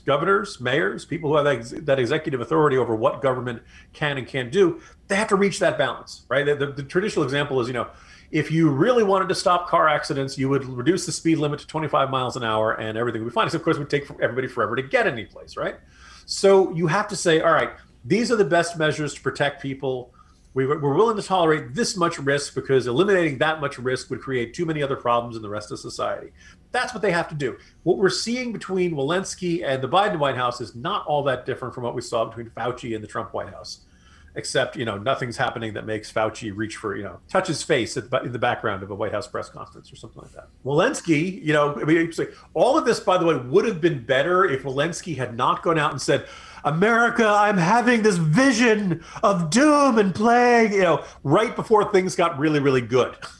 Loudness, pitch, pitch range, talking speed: -22 LUFS, 155 Hz, 135-190 Hz, 235 wpm